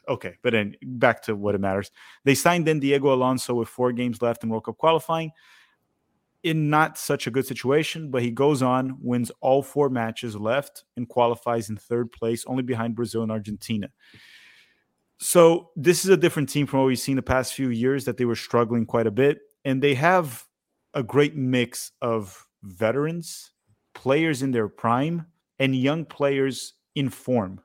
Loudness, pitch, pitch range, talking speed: -24 LUFS, 130 Hz, 115-145 Hz, 180 wpm